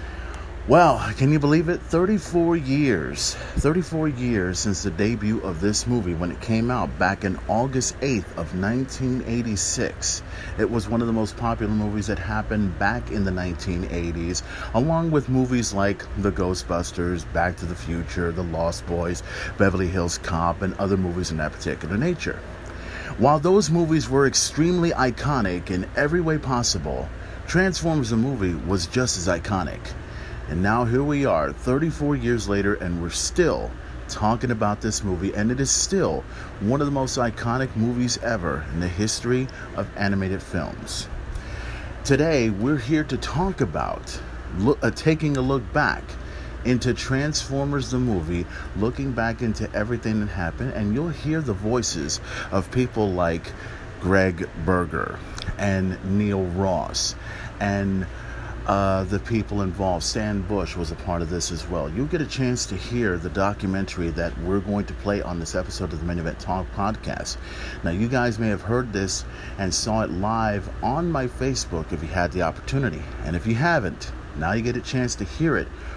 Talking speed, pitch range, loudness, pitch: 170 wpm, 90-125 Hz, -24 LUFS, 100 Hz